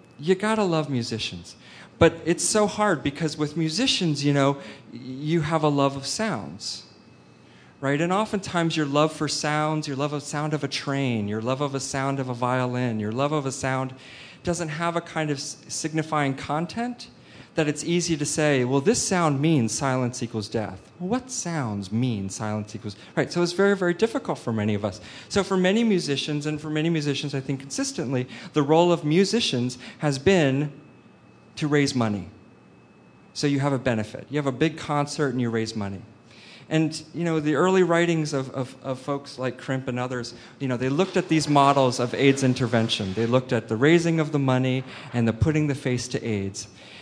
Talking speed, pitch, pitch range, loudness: 195 wpm, 145 Hz, 125-160 Hz, -24 LUFS